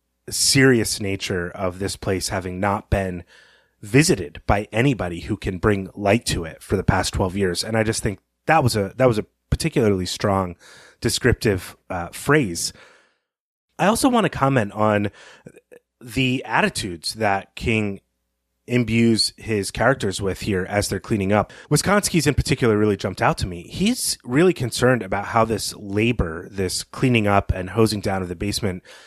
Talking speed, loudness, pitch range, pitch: 165 wpm, -21 LUFS, 95-125 Hz, 105 Hz